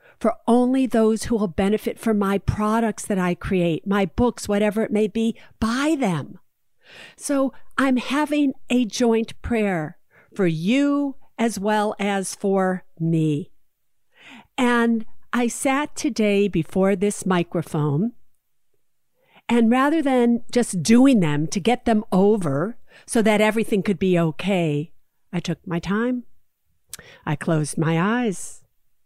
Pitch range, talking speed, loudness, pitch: 180-240 Hz, 130 wpm, -21 LUFS, 215 Hz